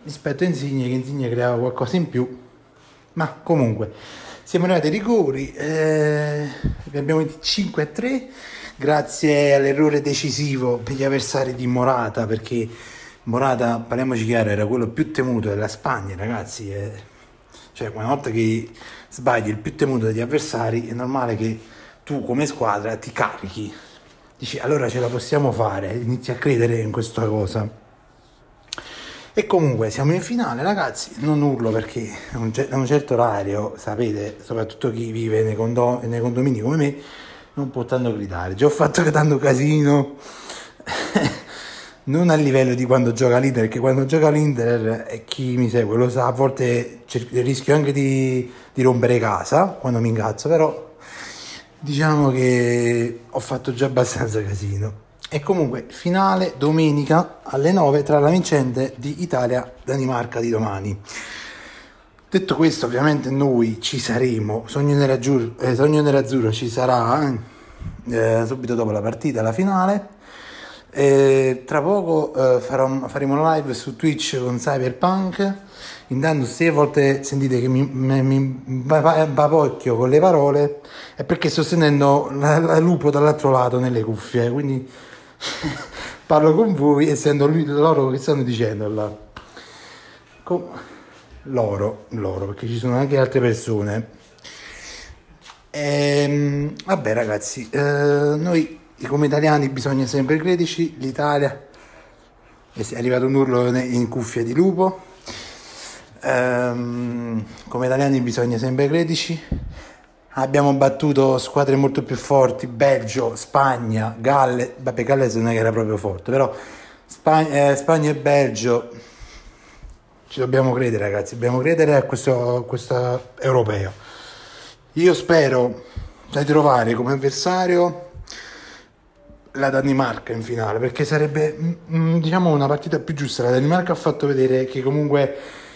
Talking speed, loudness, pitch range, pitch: 135 wpm, -20 LUFS, 120-150 Hz, 130 Hz